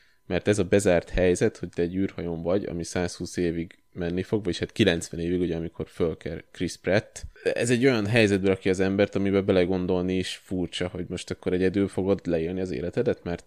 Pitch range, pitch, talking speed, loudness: 85-100 Hz, 90 Hz, 190 wpm, -26 LUFS